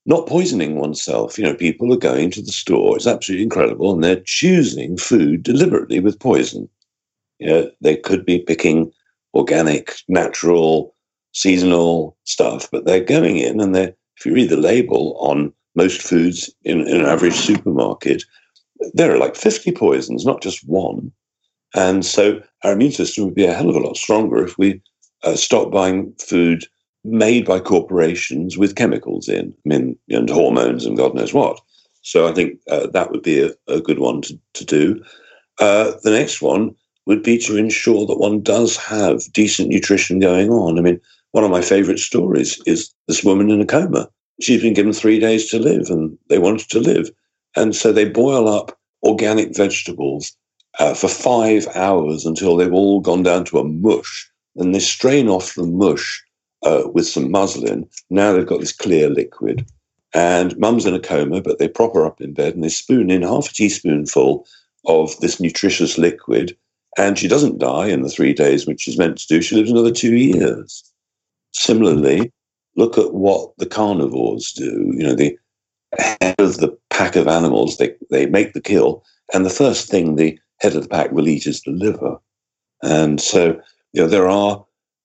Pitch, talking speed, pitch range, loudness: 95 Hz, 185 wpm, 85-110 Hz, -16 LUFS